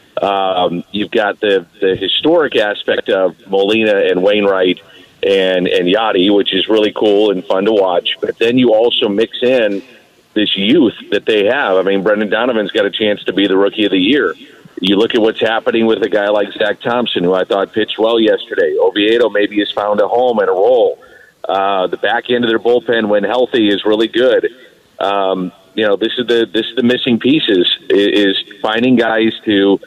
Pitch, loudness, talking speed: 115 Hz, -13 LUFS, 200 wpm